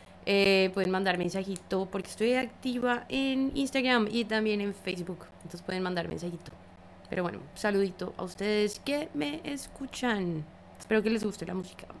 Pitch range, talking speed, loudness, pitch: 180-245 Hz, 155 wpm, -30 LUFS, 195 Hz